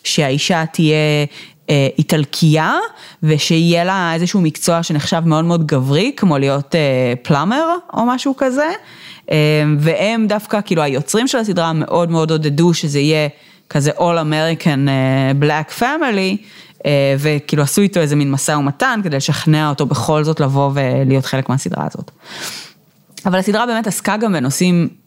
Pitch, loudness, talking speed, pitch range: 160 Hz, -15 LUFS, 135 wpm, 145-190 Hz